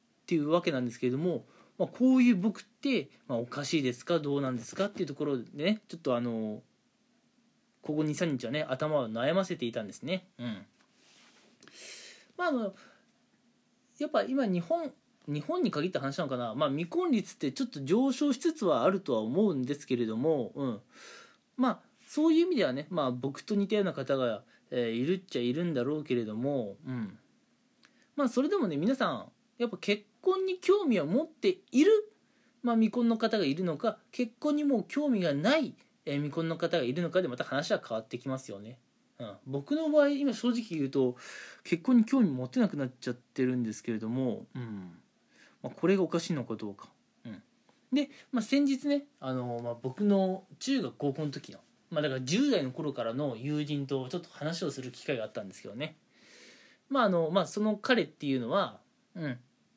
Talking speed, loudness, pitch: 365 characters per minute, -31 LUFS, 180 Hz